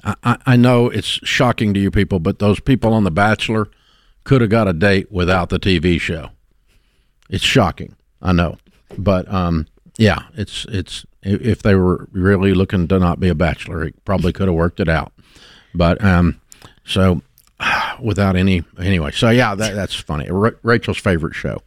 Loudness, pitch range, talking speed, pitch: -17 LUFS, 90-110 Hz, 175 wpm, 95 Hz